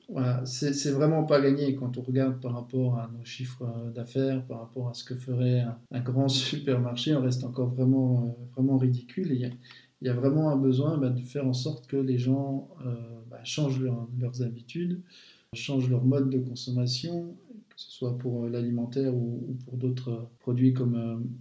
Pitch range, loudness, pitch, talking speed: 125-135 Hz, -29 LUFS, 125 Hz, 205 wpm